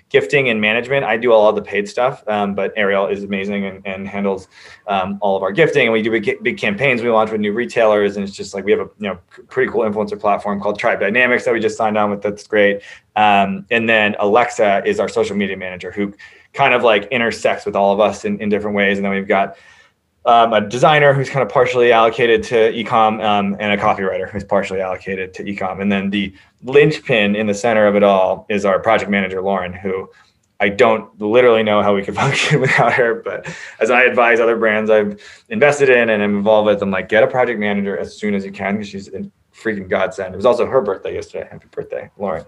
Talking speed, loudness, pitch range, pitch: 235 wpm, -16 LUFS, 100-120 Hz, 105 Hz